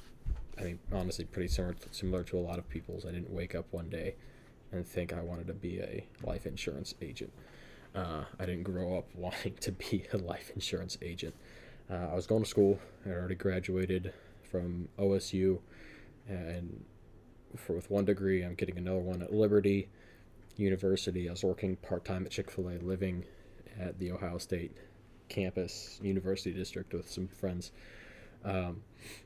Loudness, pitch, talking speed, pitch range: -37 LUFS, 95 Hz, 165 wpm, 90-100 Hz